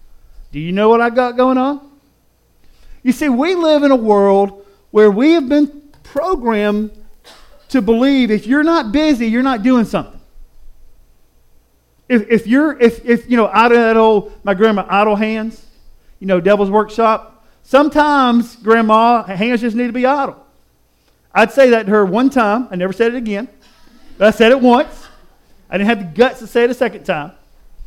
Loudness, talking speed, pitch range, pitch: -13 LUFS, 185 wpm, 205-255 Hz, 225 Hz